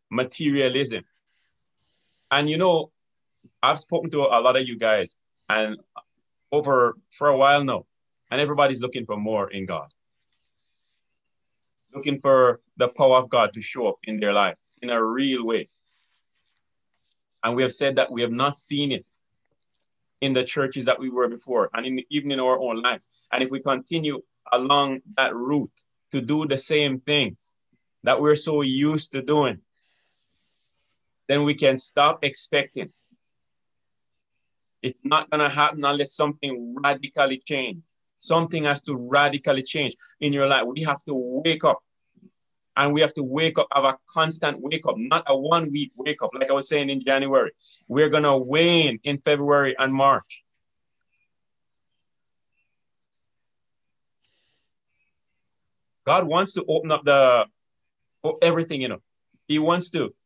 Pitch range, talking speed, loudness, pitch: 130-150 Hz, 150 wpm, -22 LUFS, 140 Hz